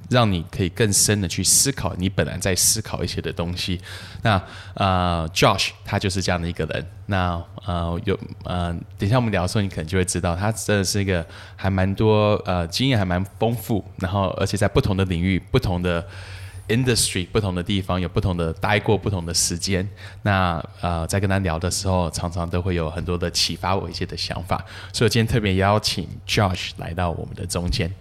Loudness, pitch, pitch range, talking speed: -22 LUFS, 95 Hz, 90-105 Hz, 330 characters per minute